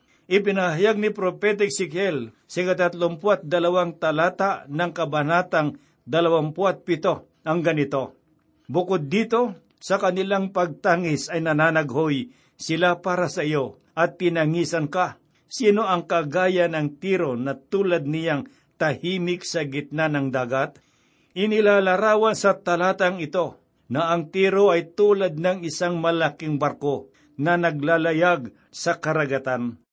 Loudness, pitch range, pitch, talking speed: -23 LUFS, 155-185 Hz, 170 Hz, 110 wpm